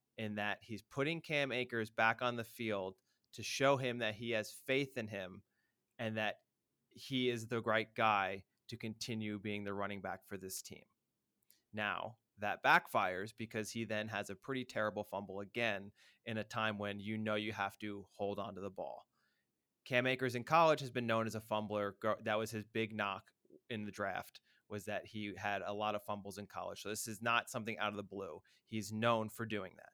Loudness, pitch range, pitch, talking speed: -39 LUFS, 100-115 Hz, 110 Hz, 205 wpm